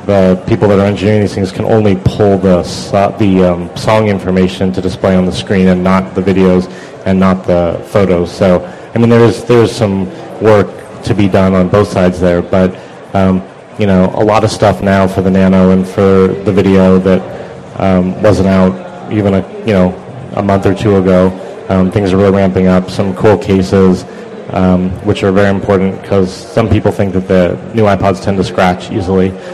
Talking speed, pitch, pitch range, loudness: 200 wpm, 95 Hz, 95-100 Hz, -10 LUFS